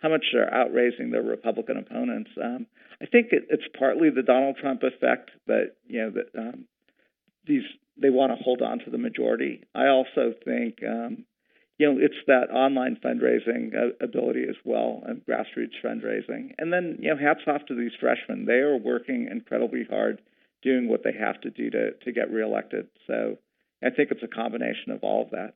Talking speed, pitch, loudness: 190 wpm, 155 Hz, -26 LUFS